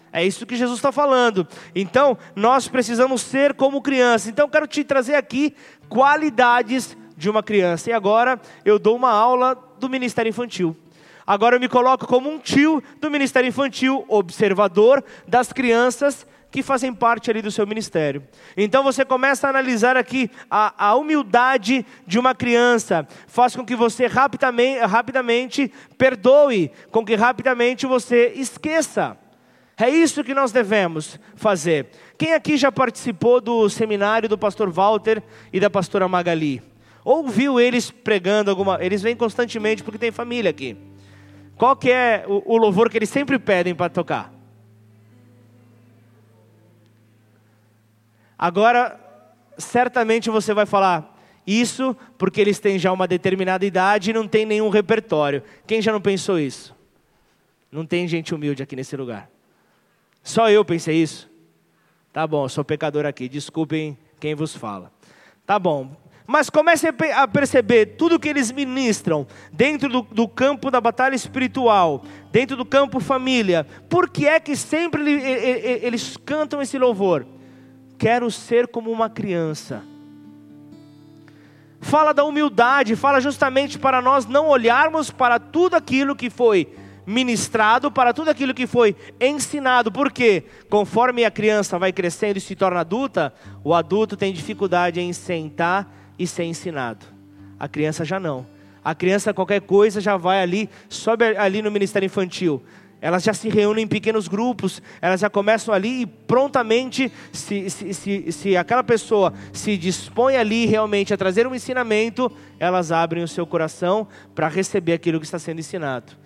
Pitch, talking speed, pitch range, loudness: 215 Hz, 150 wpm, 170-255 Hz, -19 LUFS